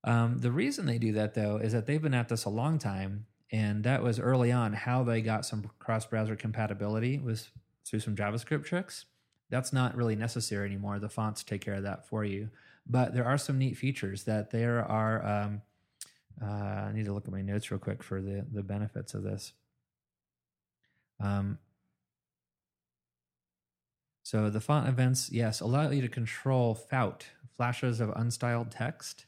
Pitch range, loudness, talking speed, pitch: 105-125 Hz, -32 LUFS, 175 wpm, 110 Hz